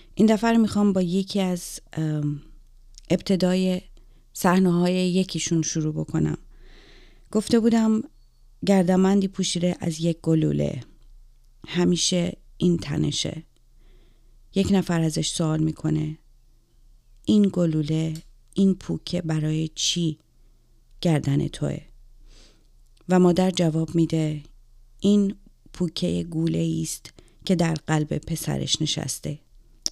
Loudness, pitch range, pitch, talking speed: -24 LUFS, 125-185 Hz, 160 Hz, 100 wpm